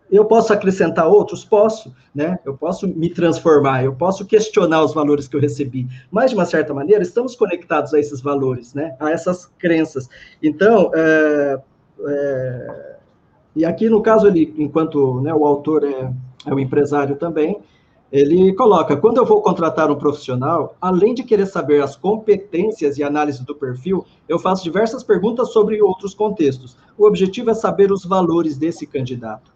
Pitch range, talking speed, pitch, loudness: 145-200 Hz, 165 wpm, 160 Hz, -17 LUFS